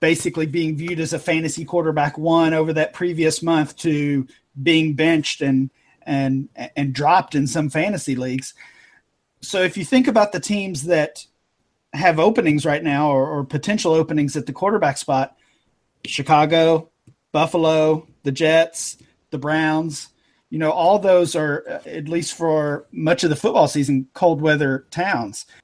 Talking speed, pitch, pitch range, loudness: 150 wpm, 155 Hz, 145-165 Hz, -19 LUFS